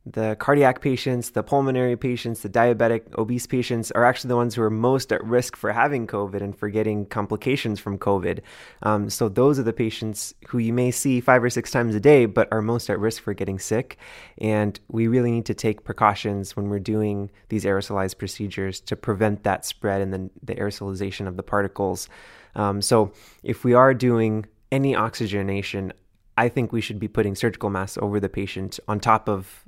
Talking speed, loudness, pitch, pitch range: 200 wpm, -23 LUFS, 110 Hz, 100-120 Hz